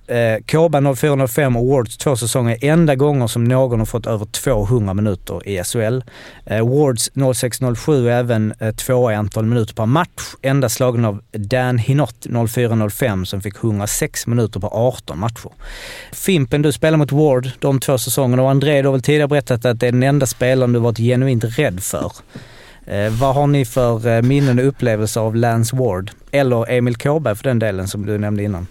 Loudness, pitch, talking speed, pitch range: -17 LUFS, 125 Hz, 180 wpm, 110-135 Hz